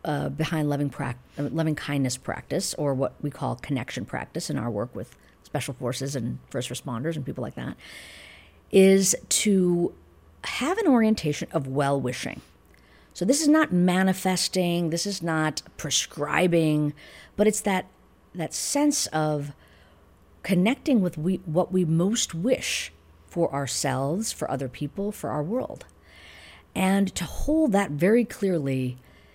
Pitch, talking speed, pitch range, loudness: 155 Hz, 145 wpm, 135-190 Hz, -25 LUFS